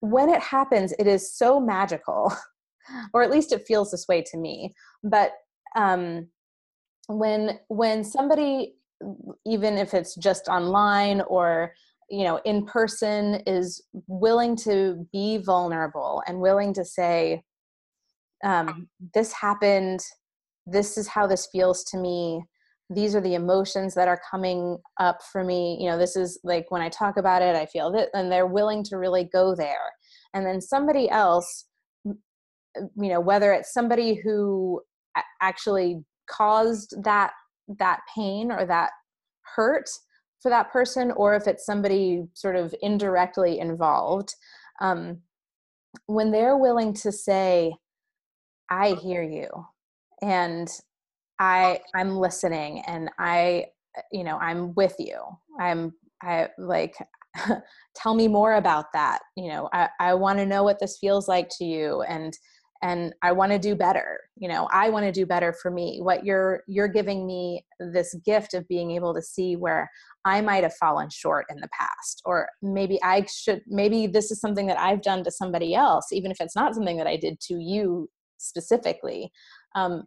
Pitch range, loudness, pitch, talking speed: 180-210 Hz, -24 LUFS, 195 Hz, 160 wpm